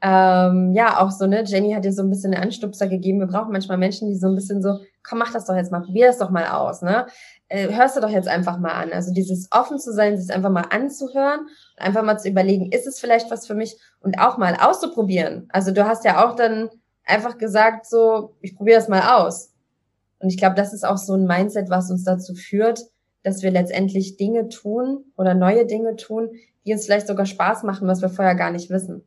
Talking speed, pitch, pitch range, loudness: 235 wpm, 200 Hz, 190-225 Hz, -20 LUFS